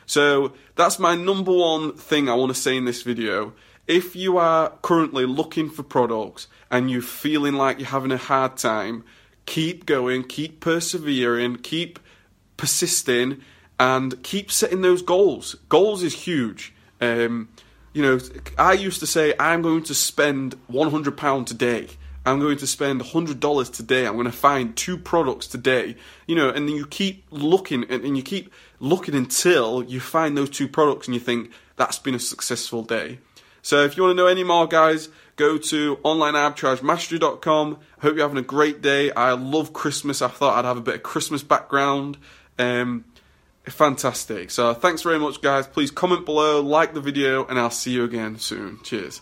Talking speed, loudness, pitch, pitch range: 180 wpm, -21 LUFS, 140 Hz, 125-160 Hz